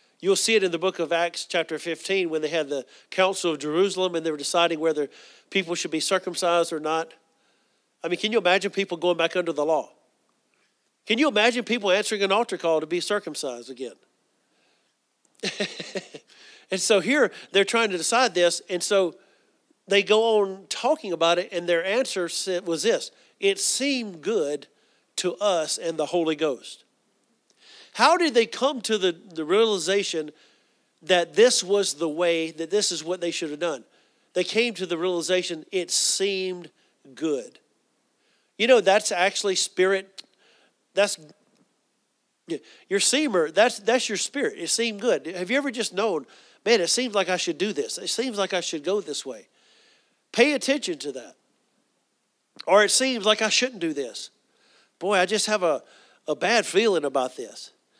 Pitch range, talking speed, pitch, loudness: 170-220 Hz, 175 wpm, 190 Hz, -24 LUFS